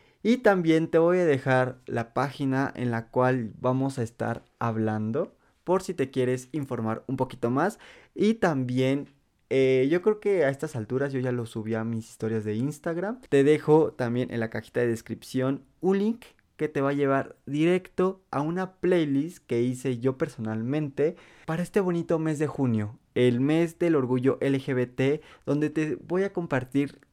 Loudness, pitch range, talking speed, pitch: -27 LUFS, 125-160 Hz, 175 wpm, 135 Hz